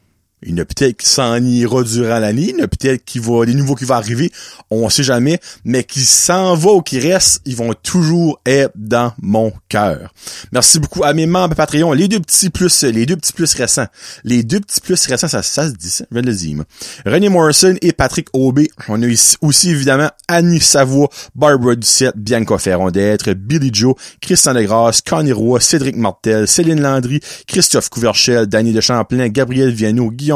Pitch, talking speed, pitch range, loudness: 130 Hz, 190 wpm, 115-155 Hz, -12 LUFS